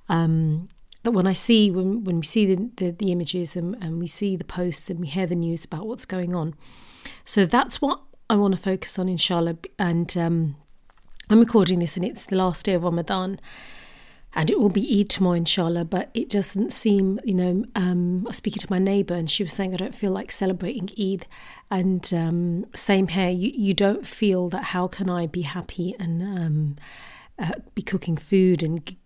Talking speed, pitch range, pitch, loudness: 210 wpm, 175-200 Hz, 185 Hz, -23 LUFS